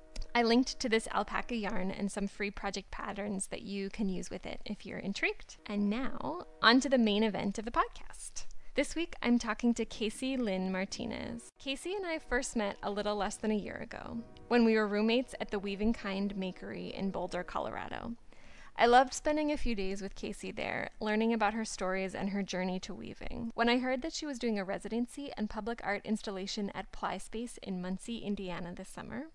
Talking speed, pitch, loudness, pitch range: 205 wpm, 215 Hz, -34 LUFS, 200-240 Hz